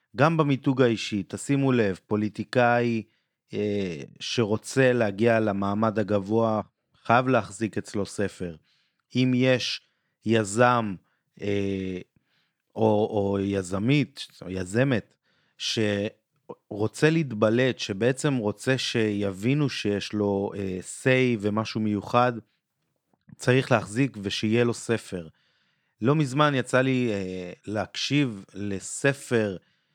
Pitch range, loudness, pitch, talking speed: 100-125 Hz, -25 LUFS, 110 Hz, 95 wpm